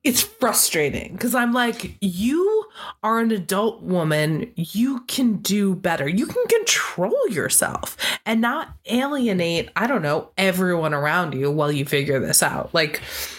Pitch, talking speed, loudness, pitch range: 205 Hz, 150 wpm, -21 LUFS, 170-245 Hz